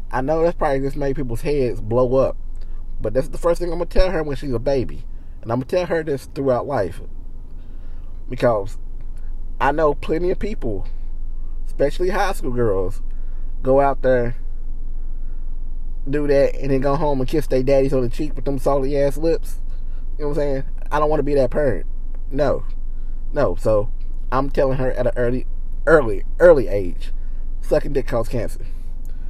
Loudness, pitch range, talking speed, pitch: -21 LUFS, 85-140 Hz, 180 wpm, 125 Hz